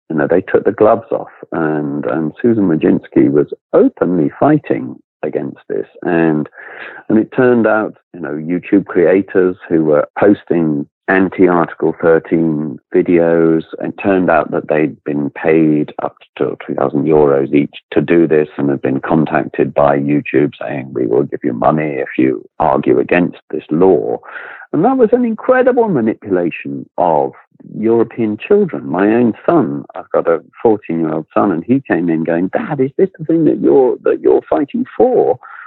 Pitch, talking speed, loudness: 90 Hz, 165 wpm, -14 LUFS